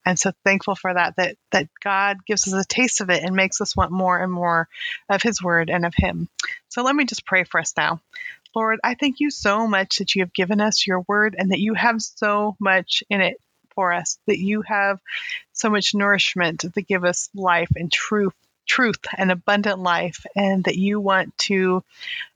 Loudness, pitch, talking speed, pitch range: -21 LUFS, 195 Hz, 210 wpm, 185-215 Hz